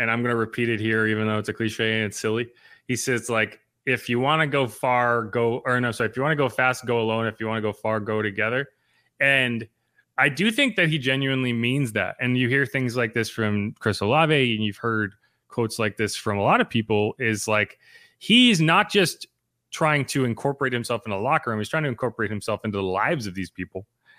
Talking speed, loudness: 240 wpm, -23 LUFS